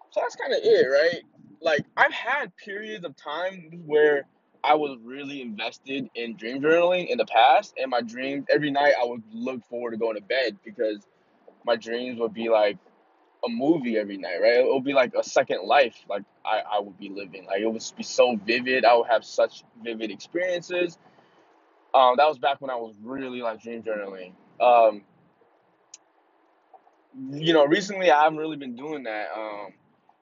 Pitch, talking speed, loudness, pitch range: 125 Hz, 185 wpm, -24 LUFS, 115-150 Hz